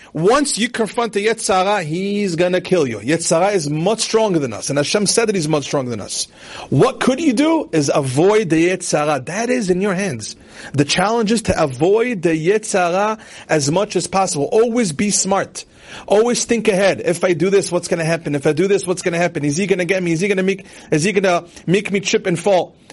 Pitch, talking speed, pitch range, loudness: 190 Hz, 220 wpm, 165-210 Hz, -17 LUFS